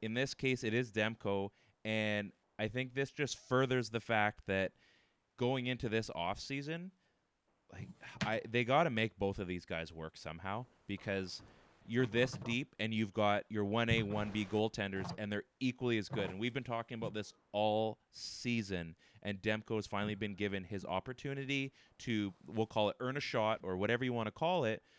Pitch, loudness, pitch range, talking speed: 110 Hz, -38 LUFS, 100-125 Hz, 185 wpm